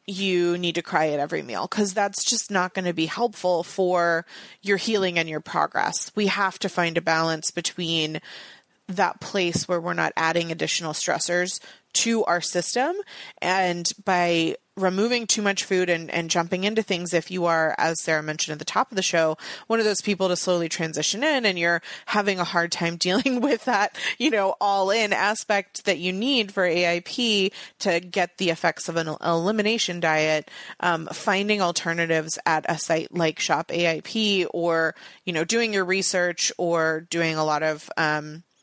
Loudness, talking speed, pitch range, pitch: -23 LUFS, 185 wpm, 165-200 Hz, 175 Hz